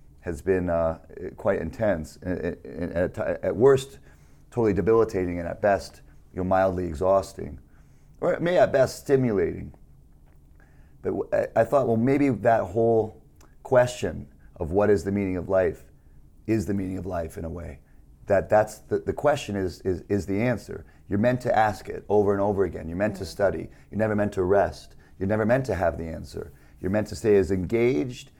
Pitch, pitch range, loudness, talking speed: 95 Hz, 80-110 Hz, -25 LUFS, 180 wpm